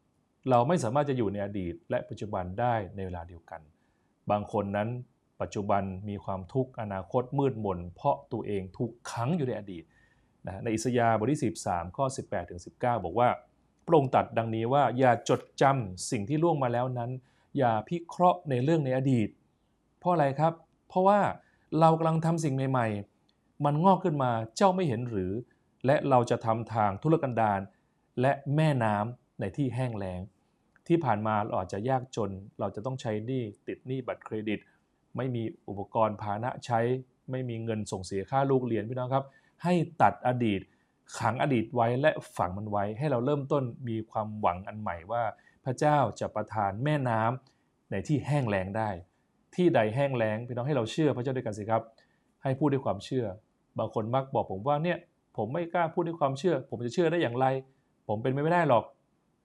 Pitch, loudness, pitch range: 120 Hz, -30 LUFS, 105-140 Hz